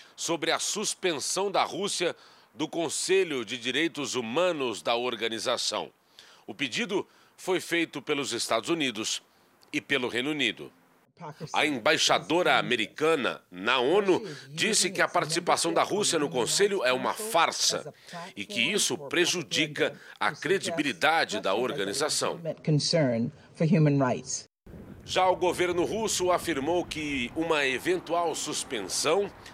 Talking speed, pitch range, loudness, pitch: 115 wpm, 140-180 Hz, -27 LUFS, 165 Hz